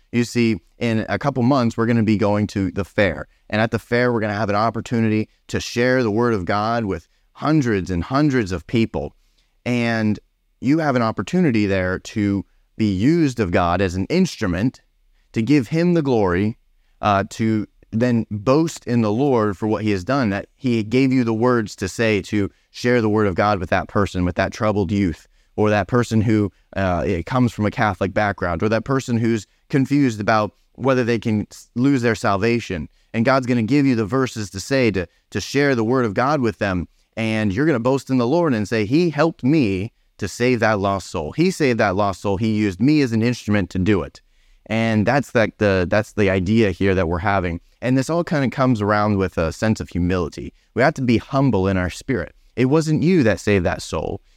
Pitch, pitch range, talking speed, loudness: 110 Hz, 100-125 Hz, 215 wpm, -20 LUFS